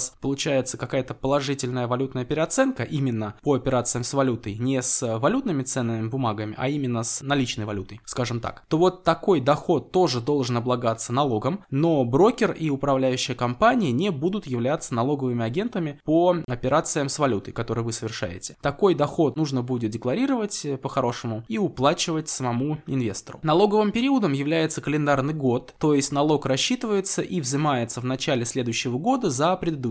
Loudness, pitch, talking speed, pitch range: -24 LUFS, 135 Hz, 150 wpm, 125-160 Hz